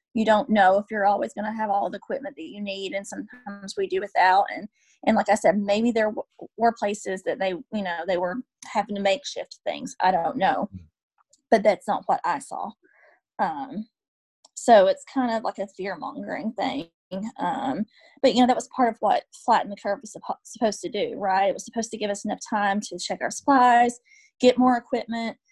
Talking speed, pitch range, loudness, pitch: 215 wpm, 195-255 Hz, -24 LUFS, 215 Hz